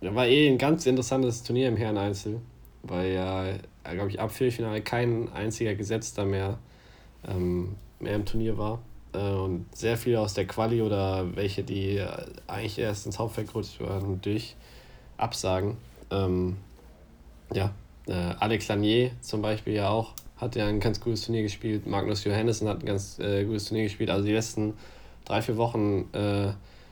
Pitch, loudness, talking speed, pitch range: 105 Hz, -29 LUFS, 165 wpm, 95-115 Hz